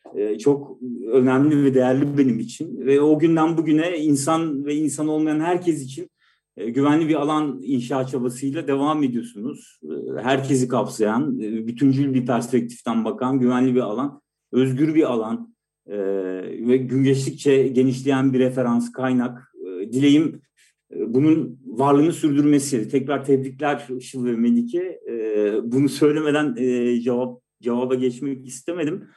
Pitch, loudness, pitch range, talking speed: 135 Hz, -21 LUFS, 125-150 Hz, 115 wpm